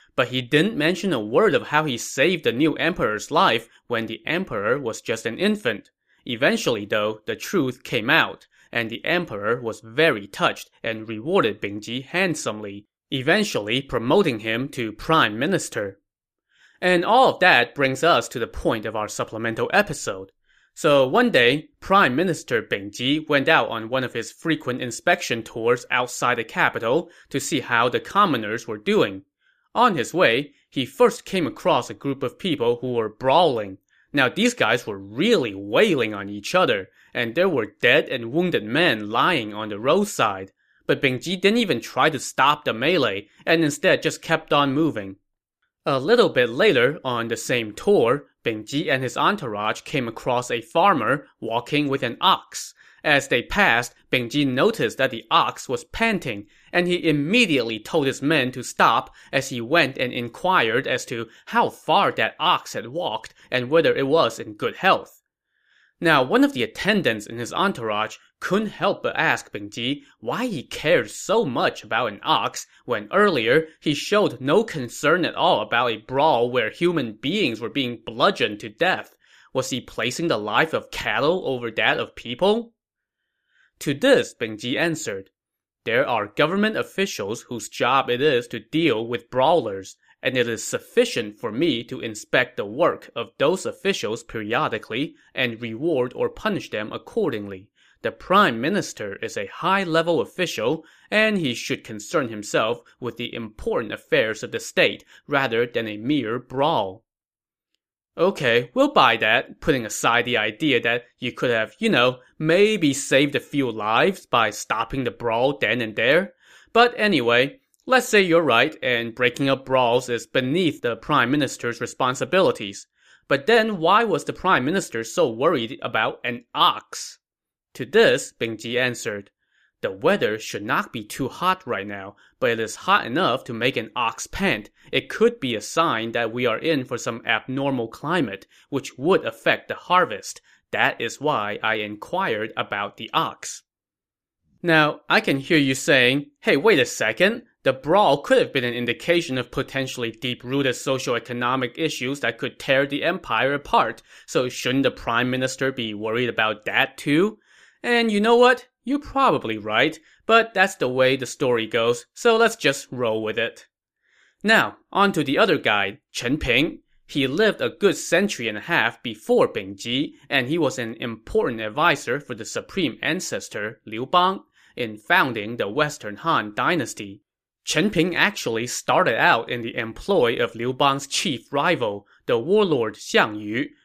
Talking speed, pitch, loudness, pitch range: 170 wpm, 135 Hz, -22 LUFS, 115-175 Hz